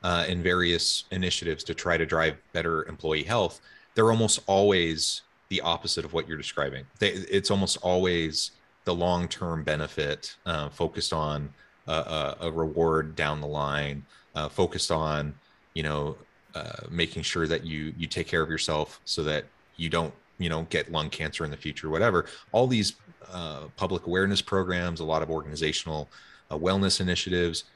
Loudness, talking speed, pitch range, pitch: -28 LUFS, 165 wpm, 80-90 Hz, 85 Hz